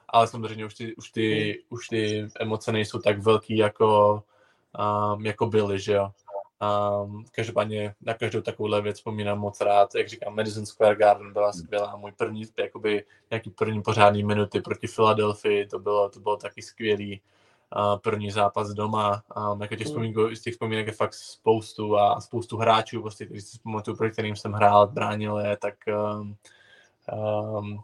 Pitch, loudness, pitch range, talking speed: 105 Hz, -25 LUFS, 105-110 Hz, 170 wpm